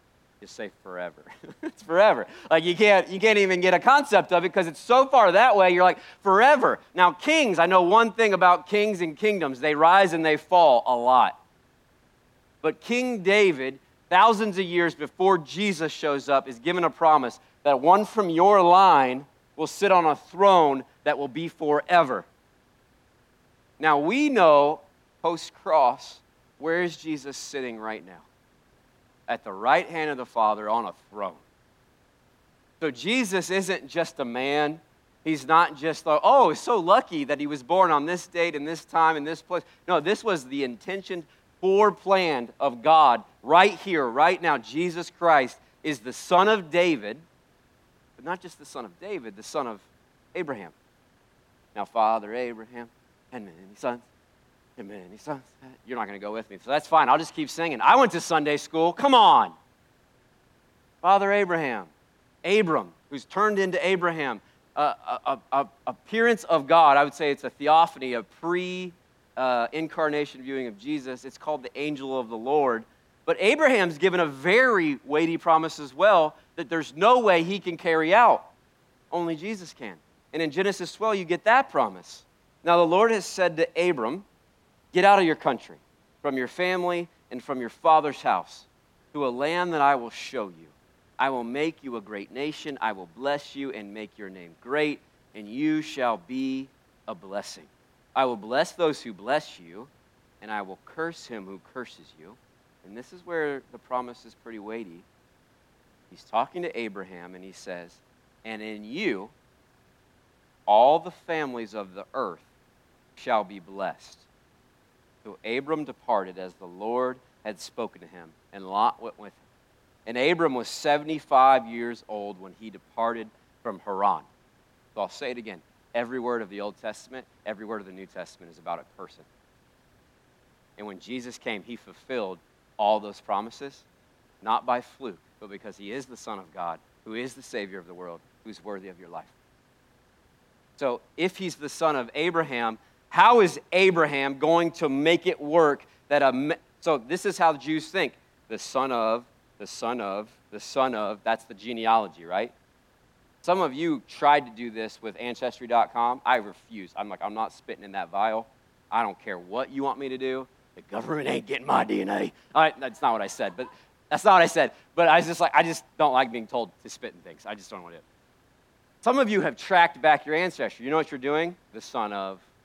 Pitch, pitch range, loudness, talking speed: 150 Hz, 120-175 Hz, -24 LUFS, 185 wpm